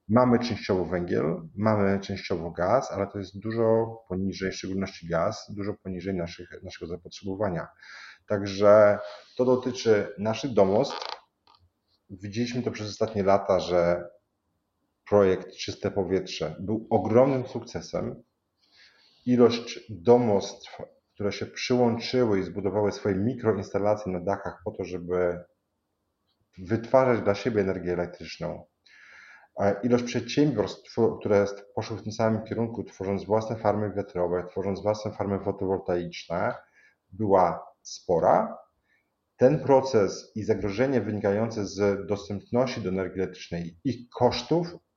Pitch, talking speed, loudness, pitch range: 105 Hz, 115 wpm, -27 LUFS, 95-115 Hz